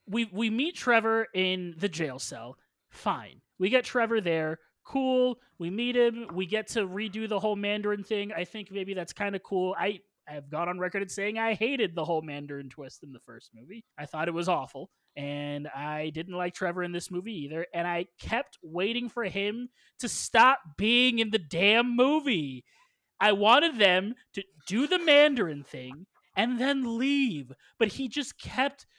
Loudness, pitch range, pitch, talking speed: -28 LUFS, 165-235 Hz, 200 Hz, 190 wpm